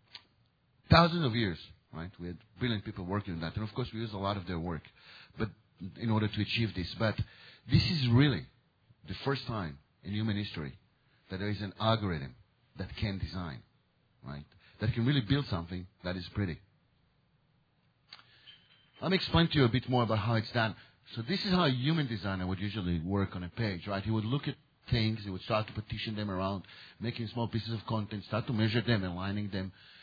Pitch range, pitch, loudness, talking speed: 95-120 Hz, 110 Hz, -33 LUFS, 205 wpm